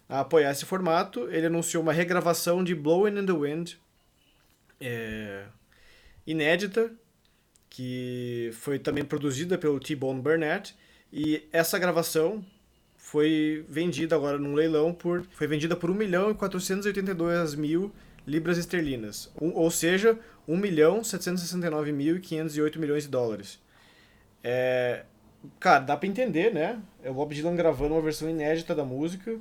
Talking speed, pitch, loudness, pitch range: 135 wpm, 160 Hz, -27 LUFS, 150-180 Hz